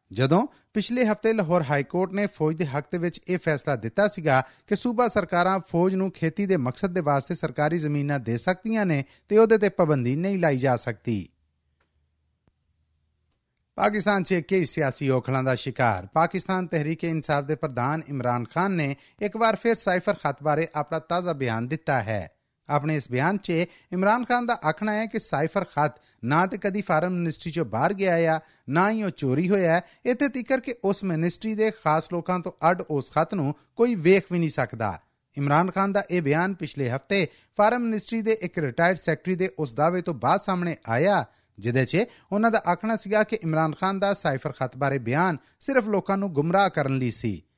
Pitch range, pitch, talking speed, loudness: 140-195 Hz, 170 Hz, 190 wpm, -25 LUFS